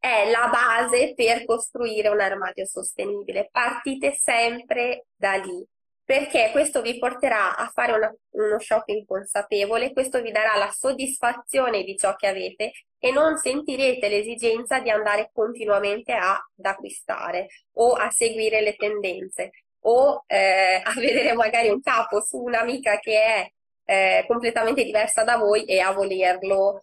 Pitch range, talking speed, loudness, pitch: 205-255 Hz, 145 wpm, -22 LUFS, 225 Hz